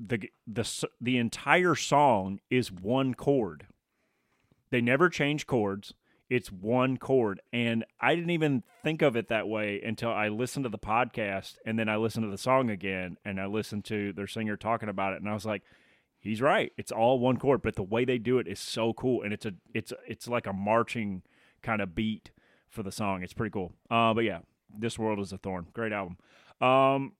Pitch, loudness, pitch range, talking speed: 115 Hz, -29 LUFS, 105-125 Hz, 210 wpm